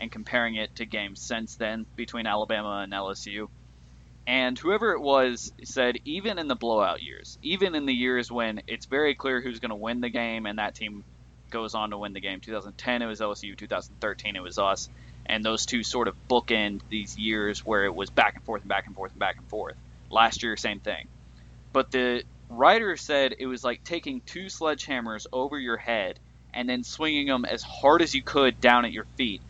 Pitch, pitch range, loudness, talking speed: 115 Hz, 105-125 Hz, -27 LUFS, 210 wpm